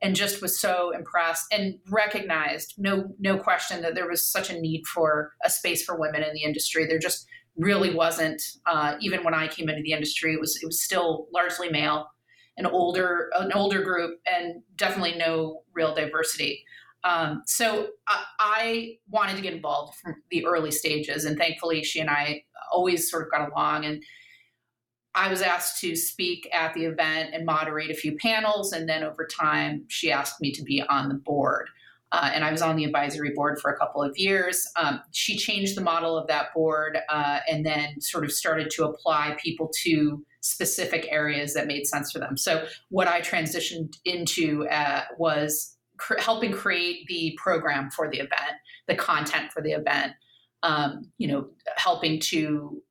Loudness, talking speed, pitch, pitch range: -26 LUFS, 185 wpm, 165 Hz, 155-180 Hz